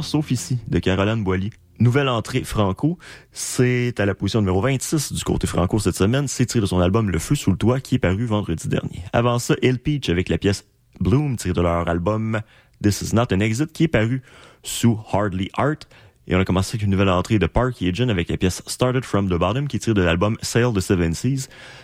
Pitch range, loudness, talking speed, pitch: 95-130 Hz, -21 LUFS, 230 wpm, 110 Hz